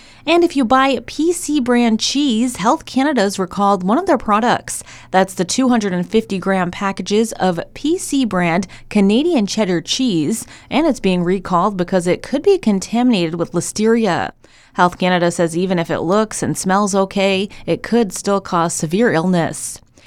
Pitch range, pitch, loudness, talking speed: 180-240 Hz, 200 Hz, -17 LUFS, 155 wpm